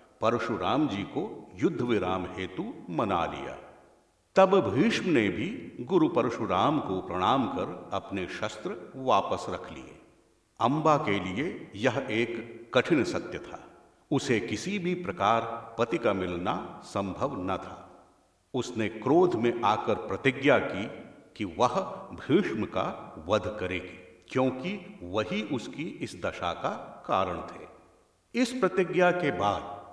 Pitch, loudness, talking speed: 115 Hz, -29 LUFS, 130 wpm